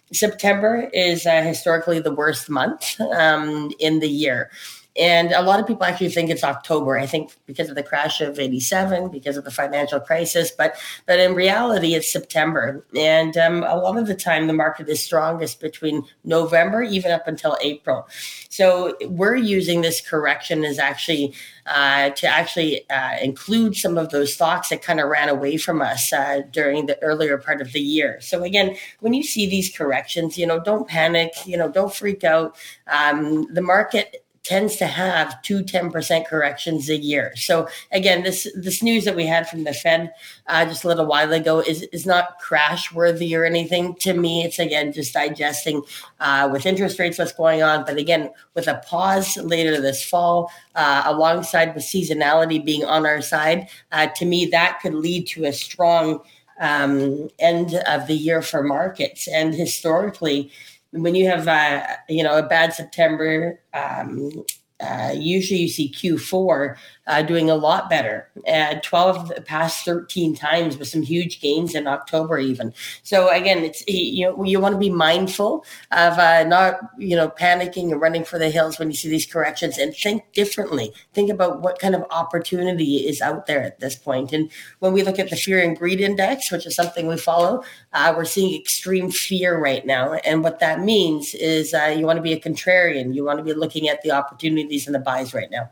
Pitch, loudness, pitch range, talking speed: 165 Hz, -20 LUFS, 150-180 Hz, 190 wpm